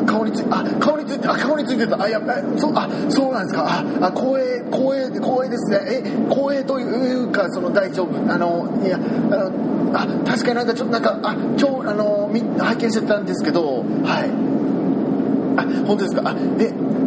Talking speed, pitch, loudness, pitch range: 295 characters per minute, 255 Hz, -20 LUFS, 230-275 Hz